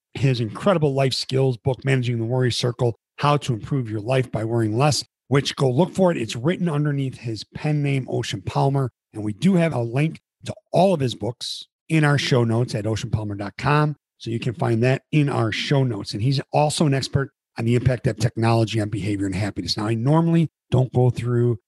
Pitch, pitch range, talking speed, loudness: 130 Hz, 115-145 Hz, 210 wpm, -22 LUFS